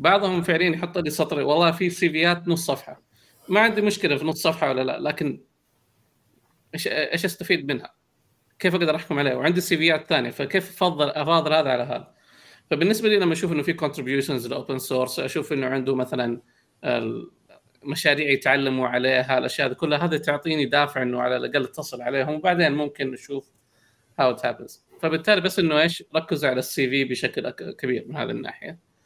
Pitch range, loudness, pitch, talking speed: 130-170 Hz, -23 LUFS, 150 Hz, 170 wpm